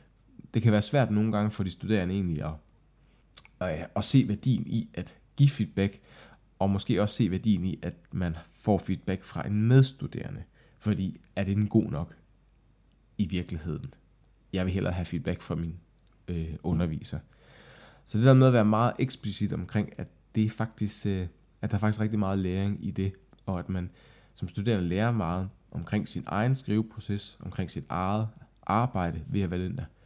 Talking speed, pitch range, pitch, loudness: 180 wpm, 90-110 Hz, 100 Hz, -29 LUFS